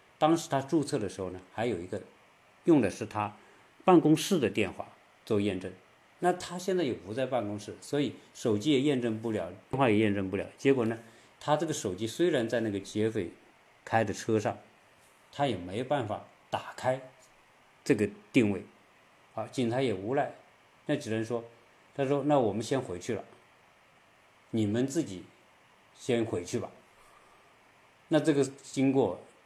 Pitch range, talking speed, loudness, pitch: 110-145 Hz, 230 characters per minute, -31 LUFS, 120 Hz